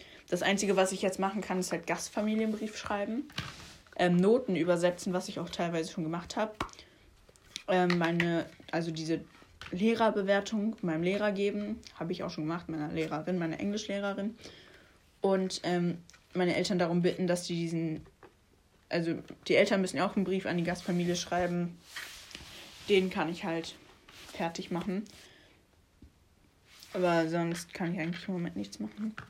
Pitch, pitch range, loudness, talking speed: 175 Hz, 165-200 Hz, -32 LUFS, 150 wpm